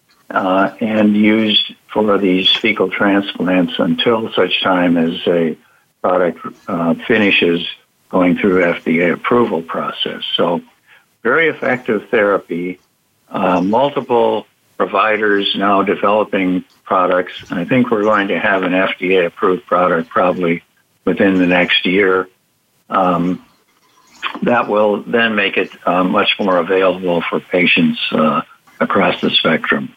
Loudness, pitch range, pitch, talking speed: -15 LUFS, 90-105 Hz, 95 Hz, 125 wpm